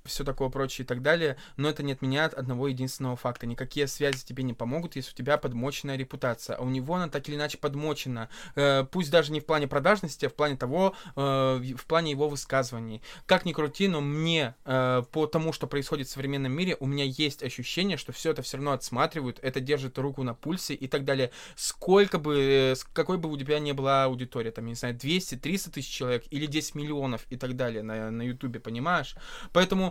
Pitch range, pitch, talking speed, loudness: 130-155 Hz, 140 Hz, 210 wpm, -29 LUFS